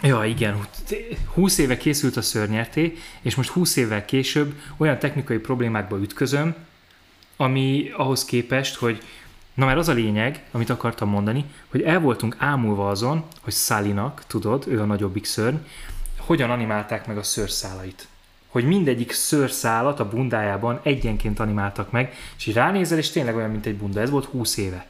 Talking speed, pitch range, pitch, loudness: 160 wpm, 105-140 Hz, 120 Hz, -23 LUFS